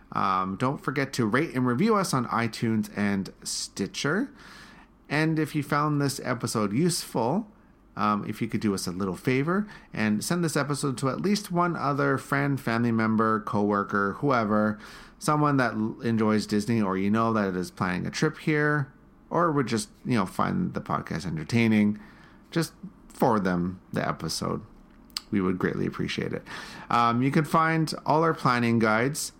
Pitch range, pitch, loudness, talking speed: 110-155 Hz, 130 Hz, -26 LUFS, 170 wpm